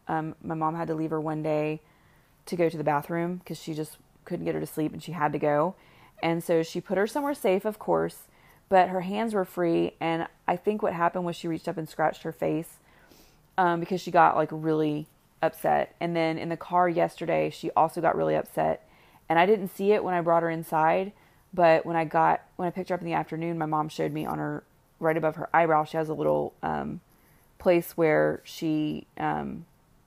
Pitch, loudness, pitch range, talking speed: 165 Hz, -27 LUFS, 155-175 Hz, 225 wpm